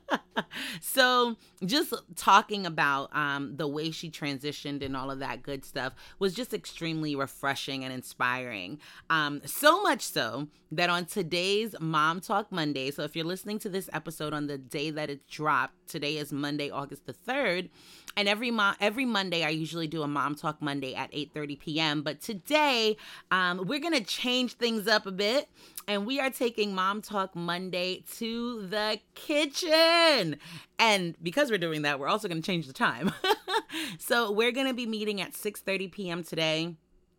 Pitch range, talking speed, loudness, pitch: 150-220 Hz, 175 wpm, -29 LUFS, 180 Hz